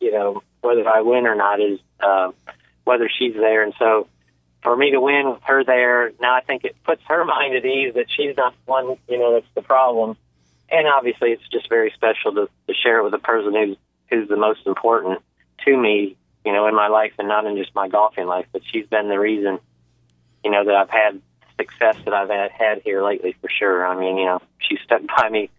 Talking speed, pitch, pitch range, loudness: 225 wpm, 110 Hz, 95-125 Hz, -19 LUFS